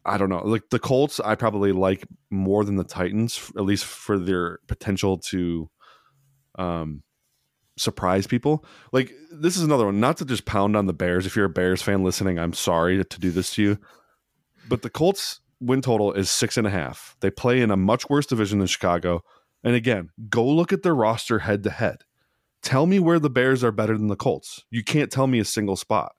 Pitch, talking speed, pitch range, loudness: 105 Hz, 215 wpm, 95-125 Hz, -23 LUFS